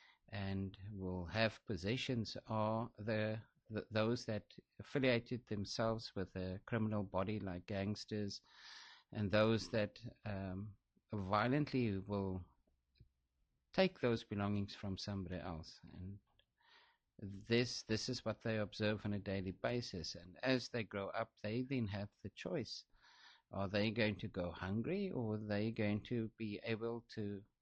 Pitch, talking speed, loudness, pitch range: 105 Hz, 140 wpm, -41 LUFS, 95-115 Hz